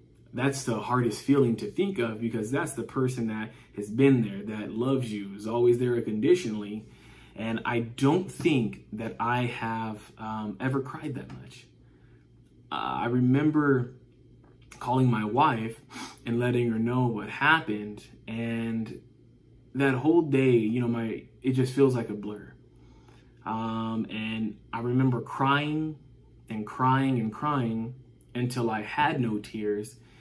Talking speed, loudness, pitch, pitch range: 145 wpm, -28 LUFS, 120 Hz, 110-130 Hz